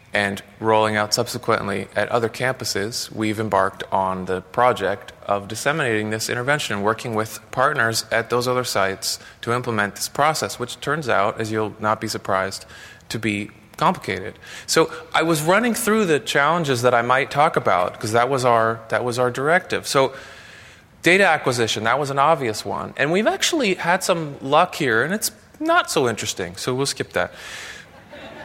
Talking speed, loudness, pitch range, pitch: 175 wpm, -21 LUFS, 105-135 Hz, 115 Hz